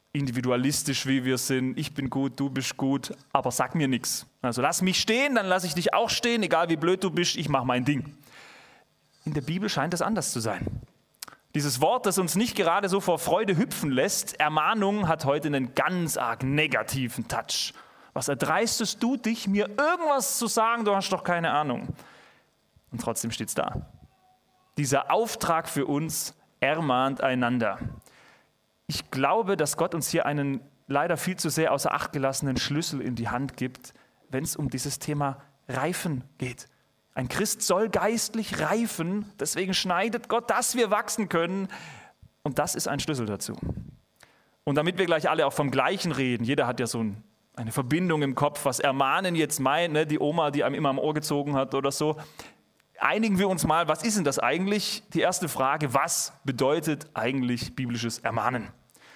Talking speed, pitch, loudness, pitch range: 185 wpm, 150 Hz, -27 LUFS, 135-185 Hz